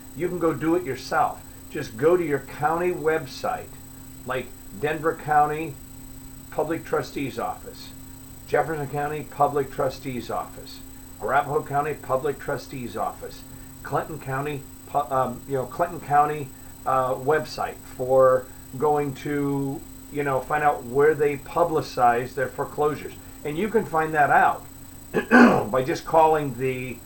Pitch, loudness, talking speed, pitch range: 140 Hz, -24 LUFS, 130 wpm, 130-150 Hz